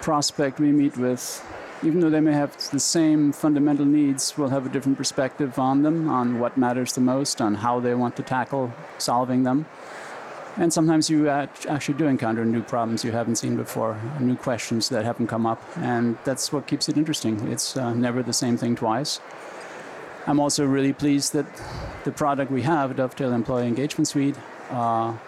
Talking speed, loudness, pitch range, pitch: 185 wpm, -23 LUFS, 120-145 Hz, 135 Hz